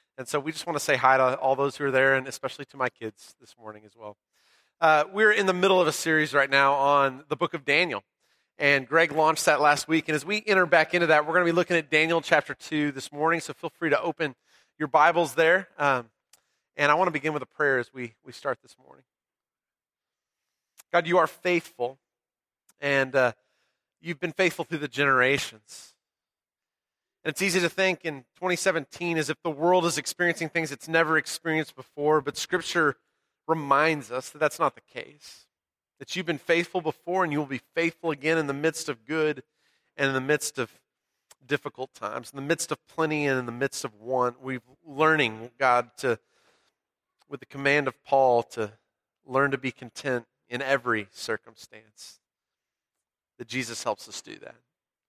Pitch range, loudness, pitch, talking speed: 130-165 Hz, -25 LUFS, 150 Hz, 195 wpm